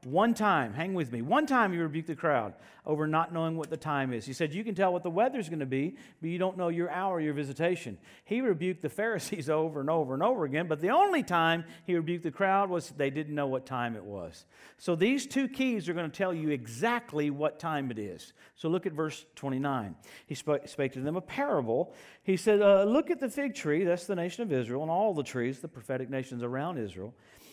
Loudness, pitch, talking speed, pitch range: -31 LUFS, 160 Hz, 240 wpm, 140-190 Hz